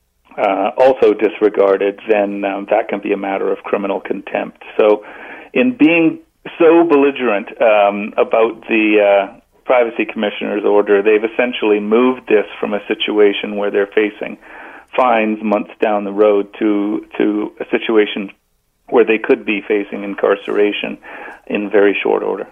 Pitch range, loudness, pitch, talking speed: 100-120 Hz, -15 LUFS, 105 Hz, 145 wpm